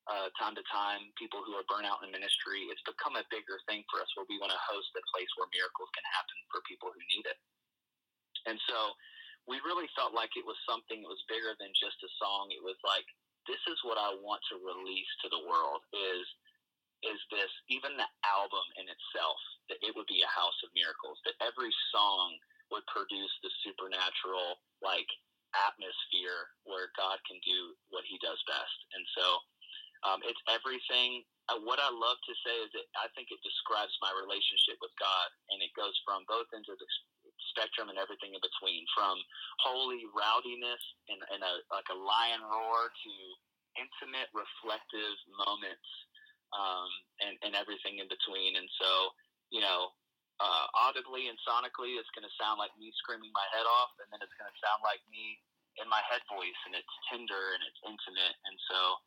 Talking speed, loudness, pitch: 190 wpm, -35 LUFS, 370 Hz